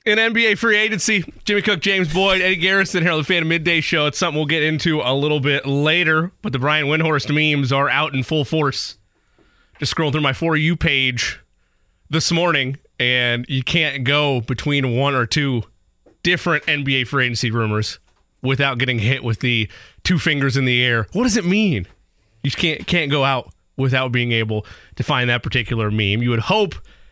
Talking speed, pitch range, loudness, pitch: 195 wpm, 125-170 Hz, -18 LUFS, 145 Hz